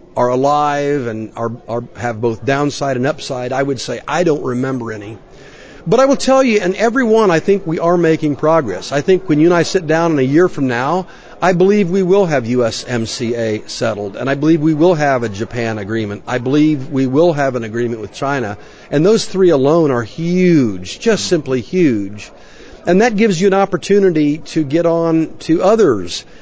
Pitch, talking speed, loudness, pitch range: 145 Hz, 200 wpm, -15 LUFS, 120-175 Hz